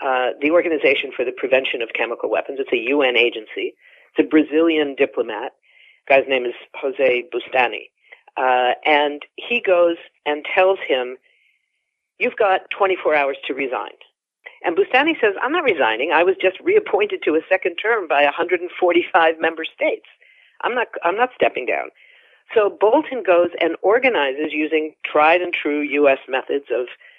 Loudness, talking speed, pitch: -19 LUFS, 160 wpm, 185 Hz